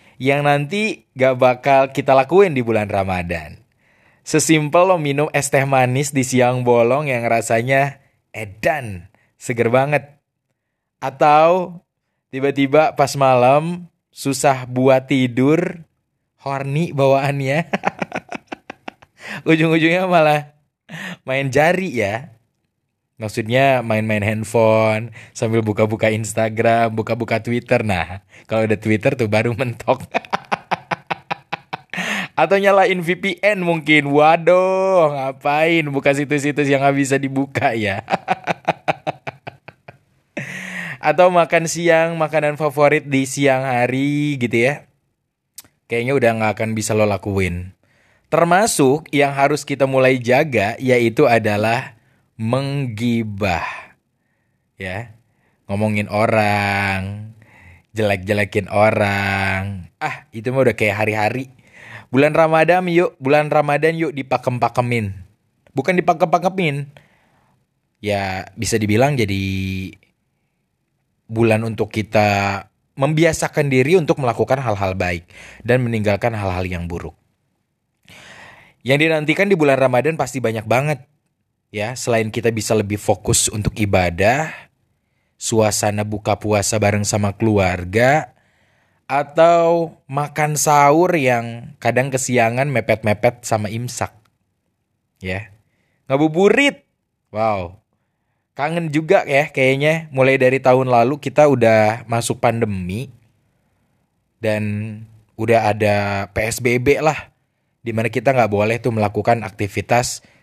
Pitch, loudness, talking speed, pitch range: 125 Hz, -17 LUFS, 100 wpm, 110-145 Hz